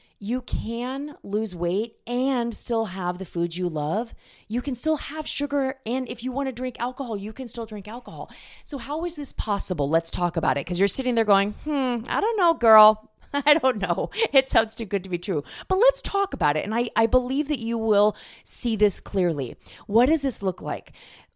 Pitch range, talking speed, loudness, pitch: 200-270 Hz, 215 wpm, -24 LUFS, 230 Hz